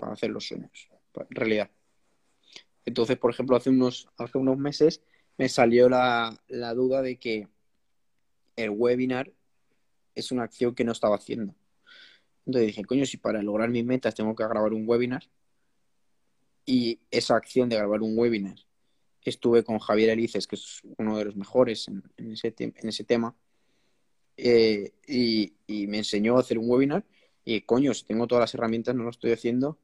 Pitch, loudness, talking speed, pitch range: 115 Hz, -26 LUFS, 175 wpm, 110-125 Hz